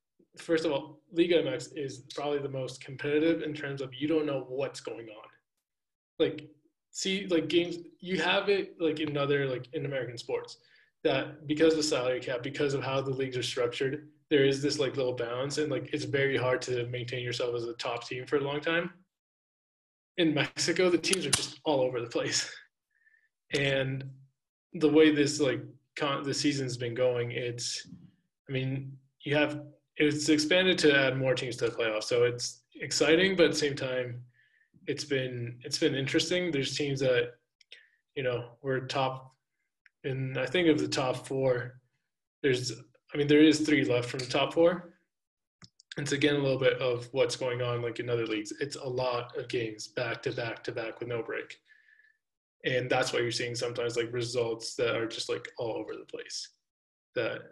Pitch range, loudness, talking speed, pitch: 130-165 Hz, -30 LUFS, 190 wpm, 145 Hz